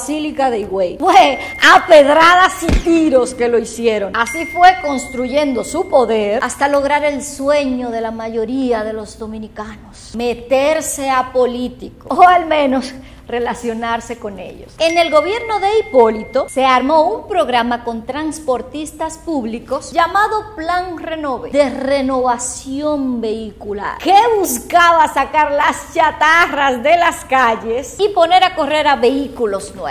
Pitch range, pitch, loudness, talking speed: 240-320 Hz, 275 Hz, -14 LUFS, 135 wpm